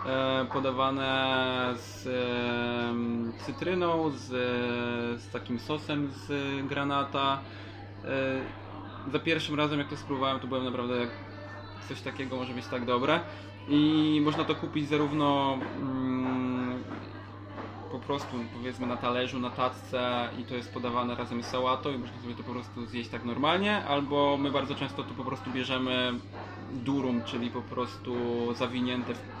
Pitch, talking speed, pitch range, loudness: 125 Hz, 135 wpm, 120-135 Hz, -31 LUFS